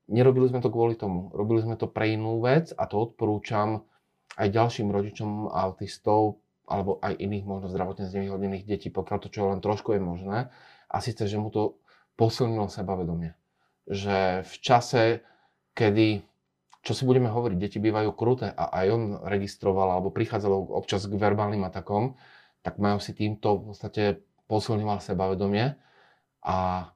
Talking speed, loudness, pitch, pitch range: 155 wpm, -27 LUFS, 105 Hz, 100-115 Hz